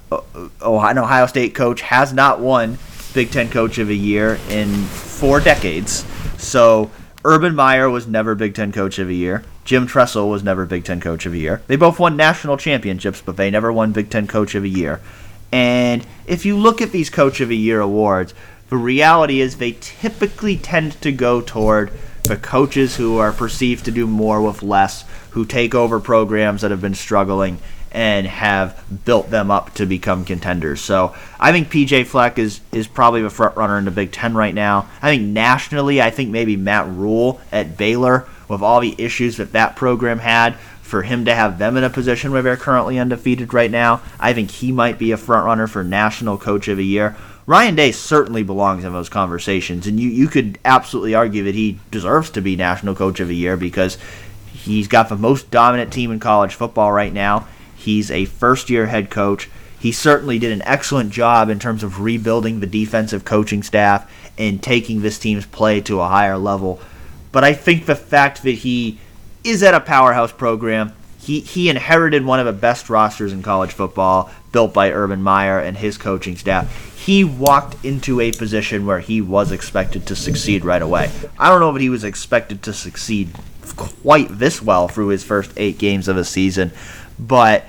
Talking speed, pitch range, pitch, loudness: 200 wpm, 100-125 Hz, 110 Hz, -16 LUFS